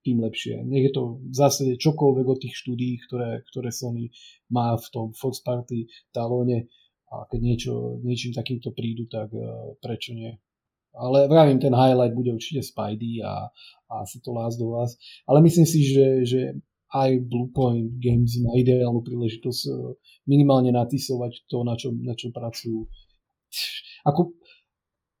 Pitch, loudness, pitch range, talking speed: 120 Hz, -24 LUFS, 115-130 Hz, 150 wpm